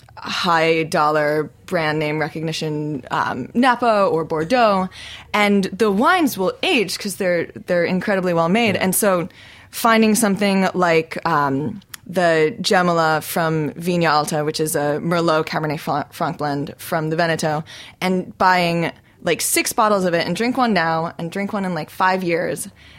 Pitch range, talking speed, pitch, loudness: 155-200 Hz, 155 wpm, 175 Hz, -19 LUFS